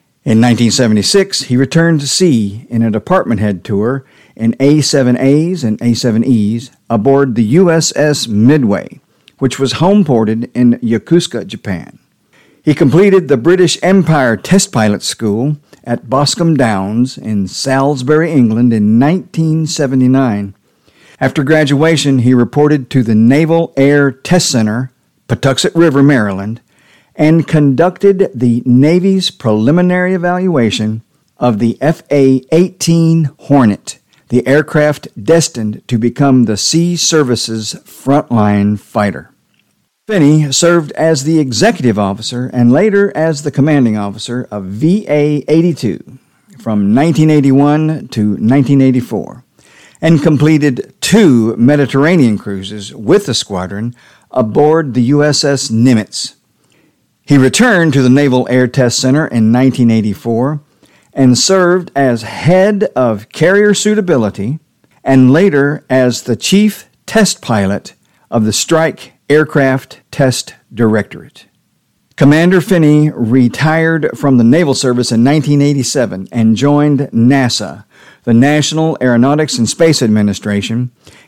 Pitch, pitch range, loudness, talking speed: 135 Hz, 115-155 Hz, -11 LUFS, 115 wpm